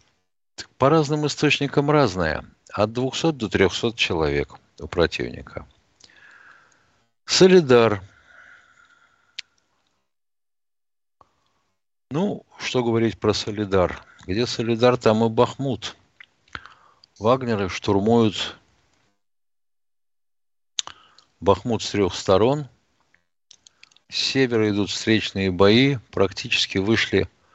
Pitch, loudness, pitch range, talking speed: 110 Hz, -21 LUFS, 90-125 Hz, 75 wpm